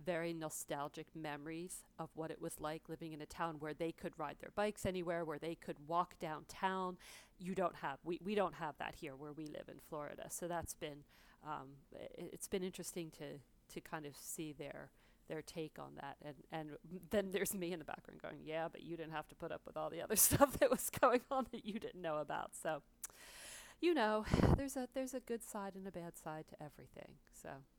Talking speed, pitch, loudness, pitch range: 220 wpm, 165 Hz, -42 LUFS, 155-190 Hz